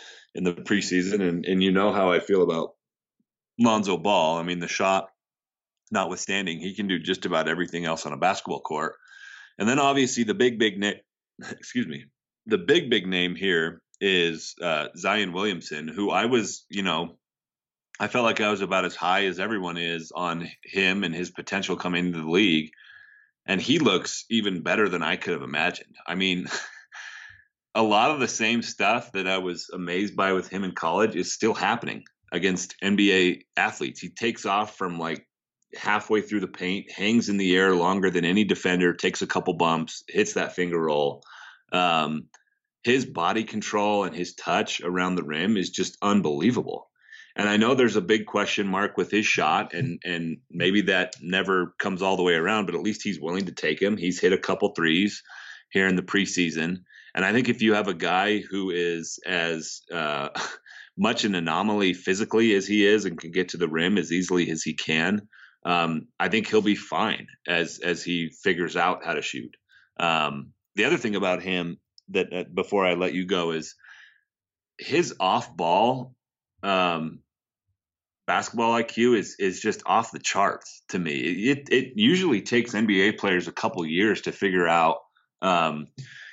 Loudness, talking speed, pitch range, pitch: -25 LUFS, 185 wpm, 85-105 Hz, 95 Hz